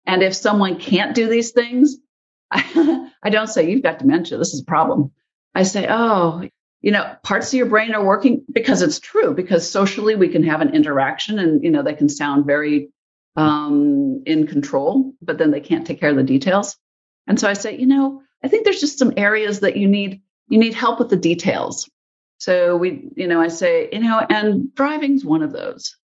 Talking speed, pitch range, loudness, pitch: 210 wpm, 180-275 Hz, -18 LUFS, 220 Hz